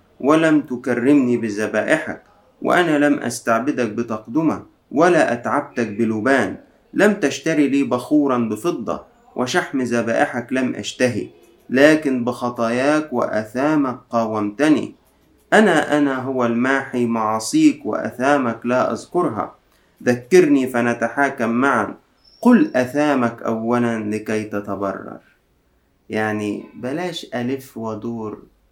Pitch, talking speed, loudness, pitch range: 125 Hz, 90 wpm, -19 LUFS, 115-145 Hz